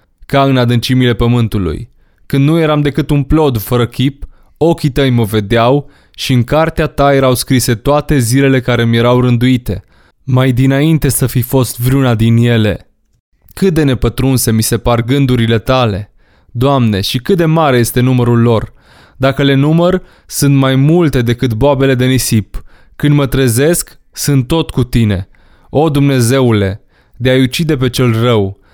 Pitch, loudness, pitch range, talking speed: 130 Hz, -11 LUFS, 115-140 Hz, 160 wpm